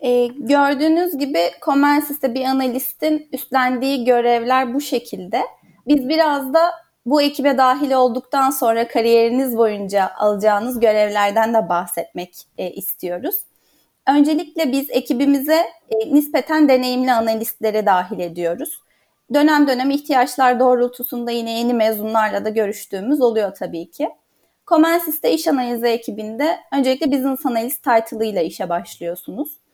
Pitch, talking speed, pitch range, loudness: 255 Hz, 115 wpm, 220-285 Hz, -18 LUFS